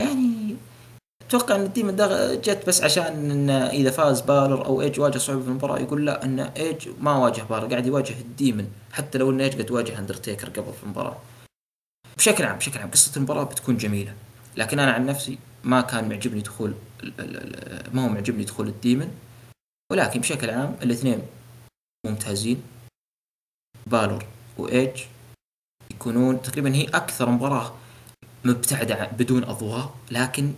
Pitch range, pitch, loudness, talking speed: 115-140 Hz, 125 Hz, -23 LUFS, 145 wpm